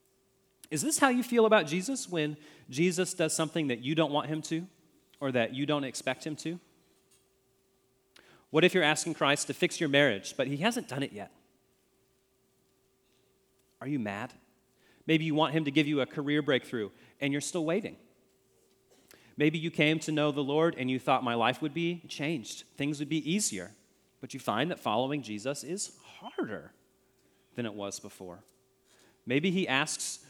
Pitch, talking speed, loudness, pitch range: 150 Hz, 180 wpm, -30 LUFS, 135-165 Hz